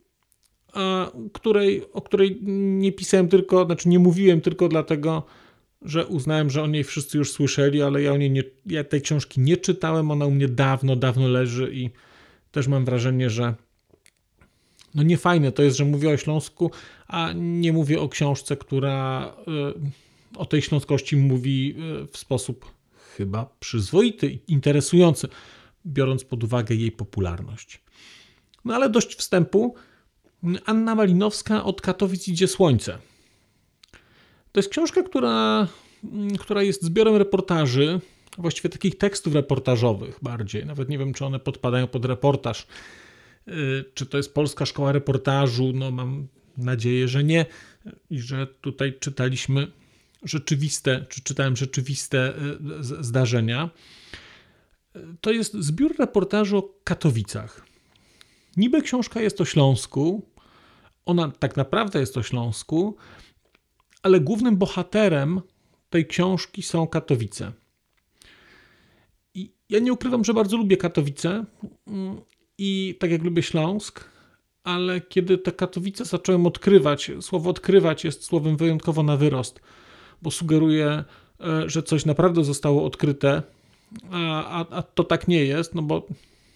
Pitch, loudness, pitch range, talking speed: 155 Hz, -23 LUFS, 135-185 Hz, 130 wpm